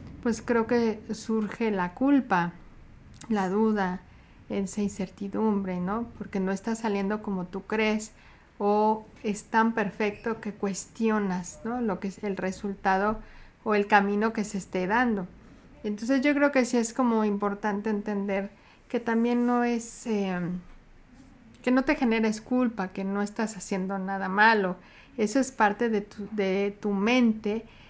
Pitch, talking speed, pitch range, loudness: 210 Hz, 150 wpm, 195-225 Hz, -27 LUFS